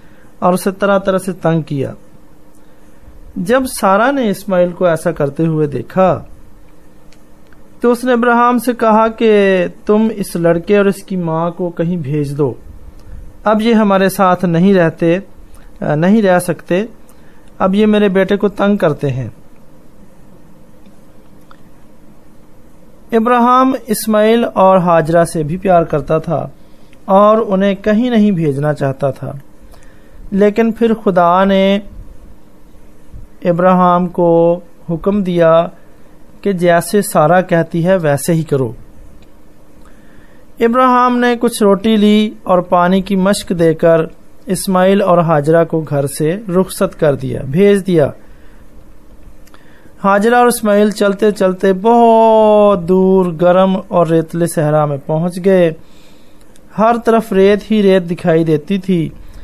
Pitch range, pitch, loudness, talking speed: 165-205 Hz, 185 Hz, -12 LUFS, 125 wpm